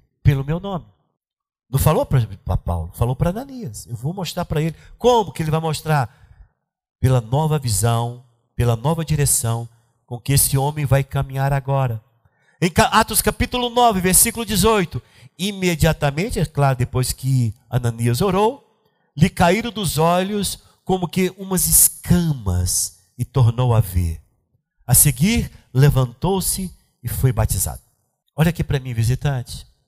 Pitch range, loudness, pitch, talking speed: 120-175 Hz, -19 LUFS, 140 Hz, 140 wpm